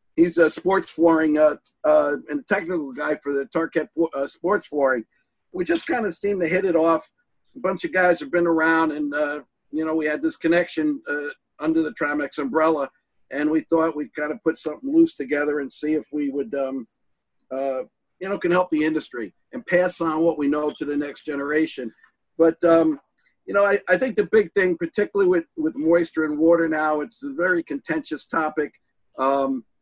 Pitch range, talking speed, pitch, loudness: 150-185 Hz, 205 wpm, 160 Hz, -22 LUFS